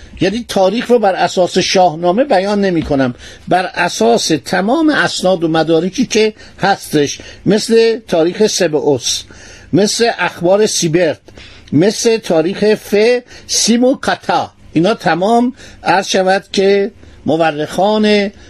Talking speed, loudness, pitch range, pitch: 110 wpm, -13 LUFS, 170-215 Hz, 190 Hz